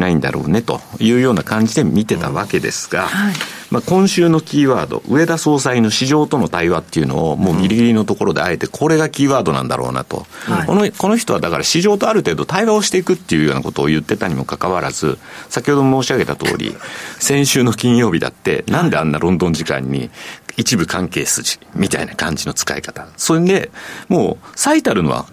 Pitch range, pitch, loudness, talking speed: 105-175 Hz, 140 Hz, -16 LUFS, 420 characters per minute